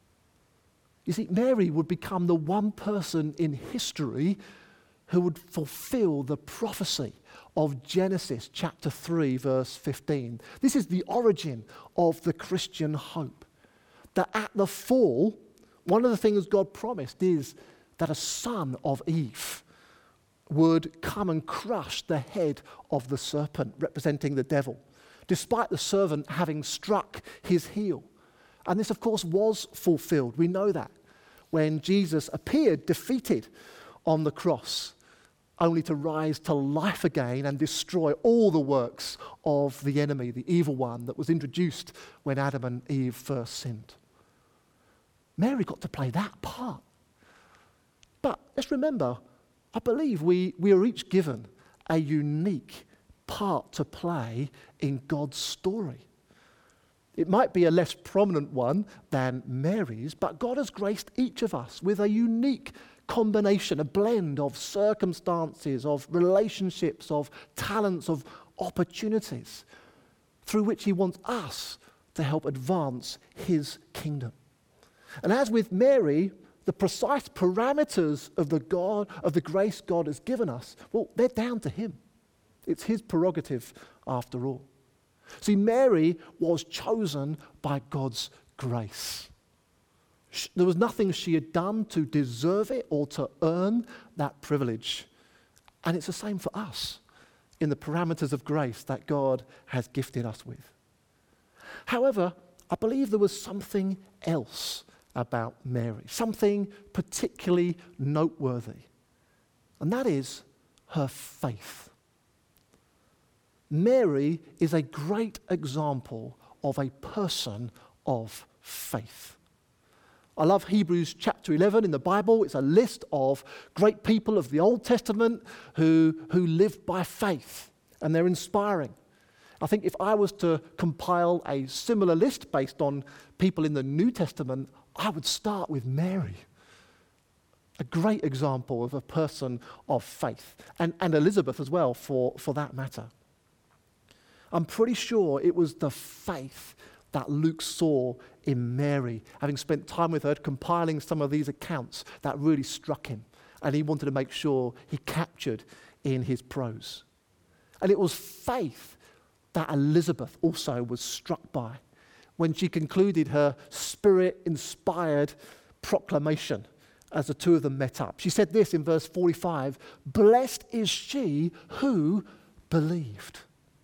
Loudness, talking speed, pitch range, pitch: -28 LUFS, 140 wpm, 140-195 Hz, 160 Hz